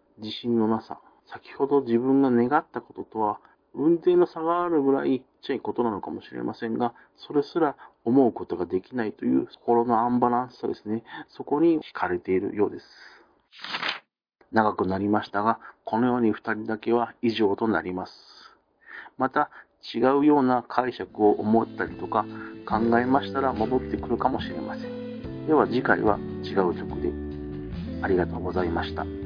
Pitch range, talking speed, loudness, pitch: 105-135 Hz, 335 characters per minute, -26 LUFS, 115 Hz